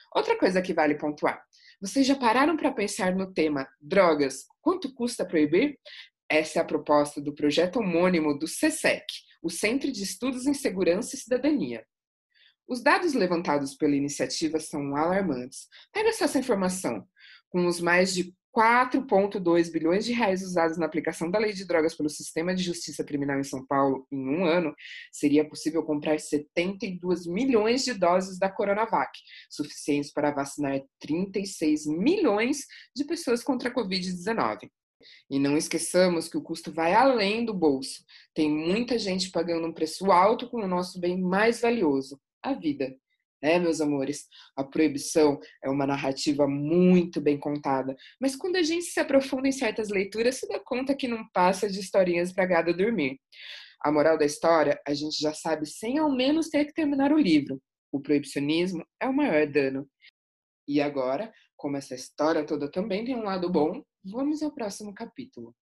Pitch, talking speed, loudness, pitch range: 175 Hz, 165 wpm, -26 LUFS, 150-230 Hz